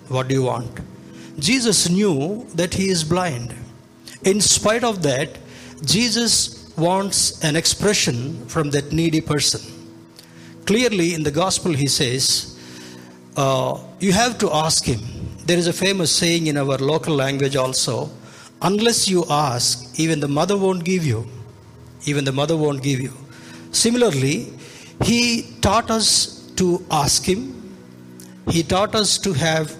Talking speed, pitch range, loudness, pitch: 145 wpm, 125-185 Hz, -19 LUFS, 155 Hz